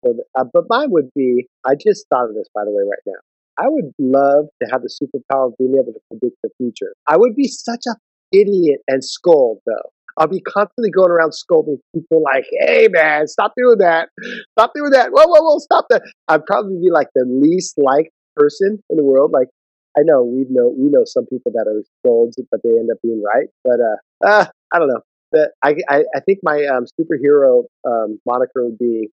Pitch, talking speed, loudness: 165 Hz, 220 wpm, -15 LUFS